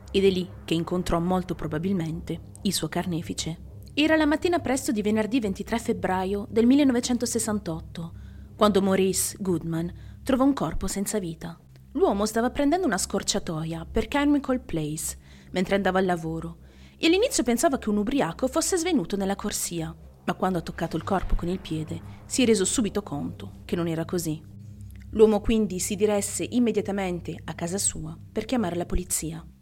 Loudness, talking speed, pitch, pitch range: -26 LUFS, 160 wpm, 195 Hz, 165-230 Hz